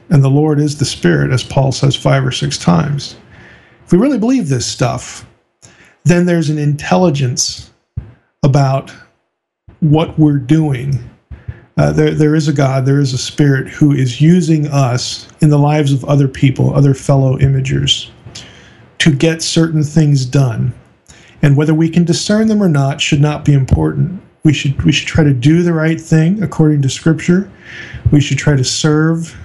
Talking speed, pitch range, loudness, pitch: 175 wpm, 135-160 Hz, -13 LUFS, 145 Hz